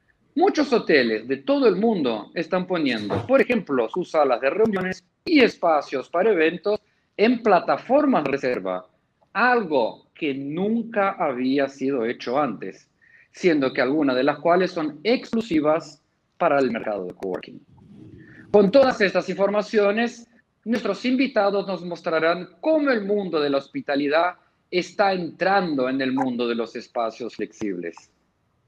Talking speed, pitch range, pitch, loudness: 135 wpm, 145-225 Hz, 185 Hz, -22 LUFS